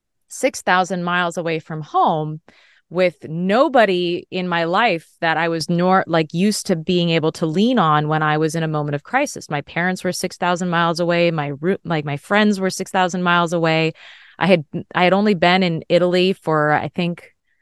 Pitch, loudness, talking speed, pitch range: 175 Hz, -18 LUFS, 185 wpm, 160-185 Hz